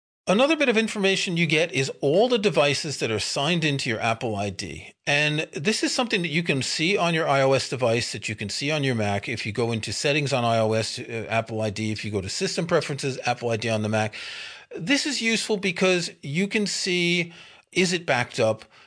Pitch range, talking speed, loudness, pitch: 115-185 Hz, 215 wpm, -24 LUFS, 145 Hz